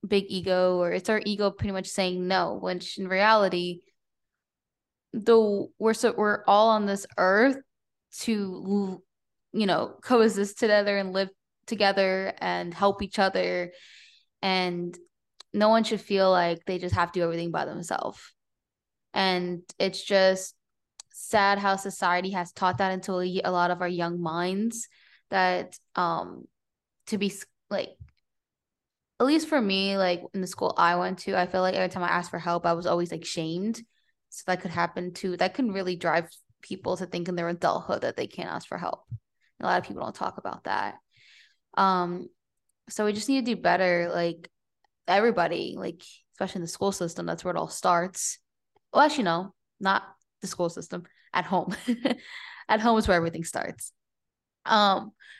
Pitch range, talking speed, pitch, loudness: 175-210 Hz, 175 wpm, 190 Hz, -26 LUFS